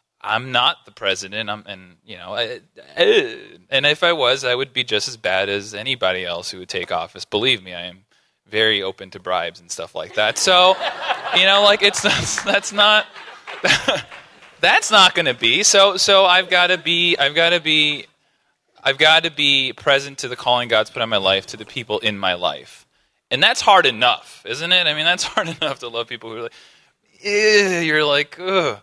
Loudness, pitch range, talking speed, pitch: -16 LUFS, 110-185 Hz, 210 wpm, 145 Hz